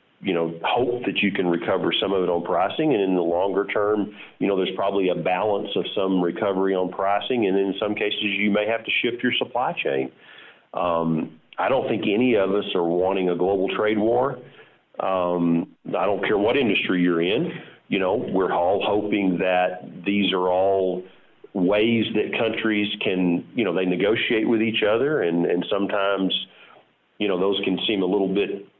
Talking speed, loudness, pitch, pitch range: 190 wpm, -22 LUFS, 95 Hz, 90-105 Hz